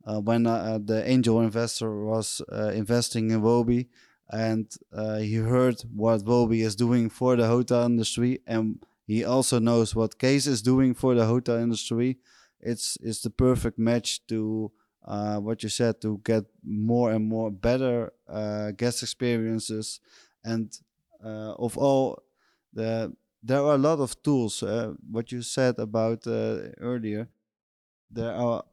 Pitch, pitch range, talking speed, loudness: 115 Hz, 110-120 Hz, 155 wpm, -26 LUFS